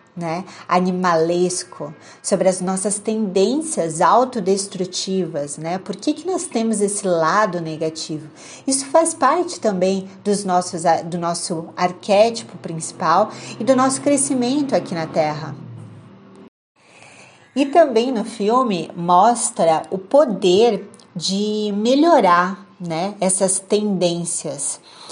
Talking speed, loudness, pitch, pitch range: 110 wpm, -19 LUFS, 190 Hz, 175-225 Hz